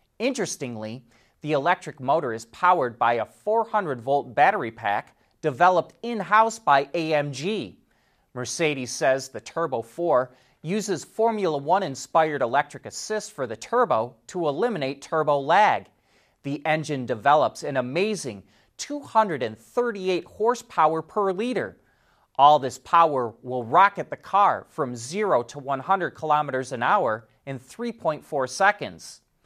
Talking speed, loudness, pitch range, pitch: 125 wpm, -24 LUFS, 130-195 Hz, 150 Hz